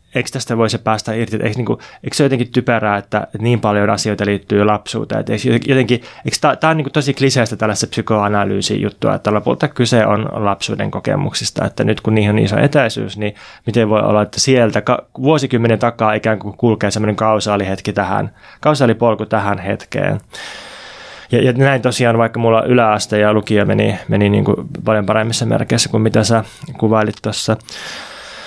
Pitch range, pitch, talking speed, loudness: 105-125 Hz, 110 Hz, 160 wpm, -15 LUFS